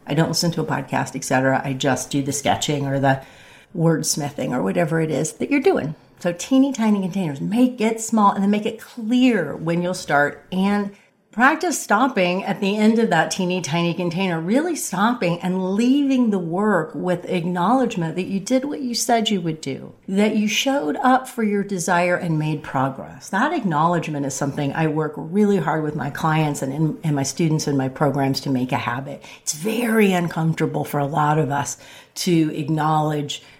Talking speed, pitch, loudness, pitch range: 195 wpm, 175 Hz, -21 LUFS, 150-210 Hz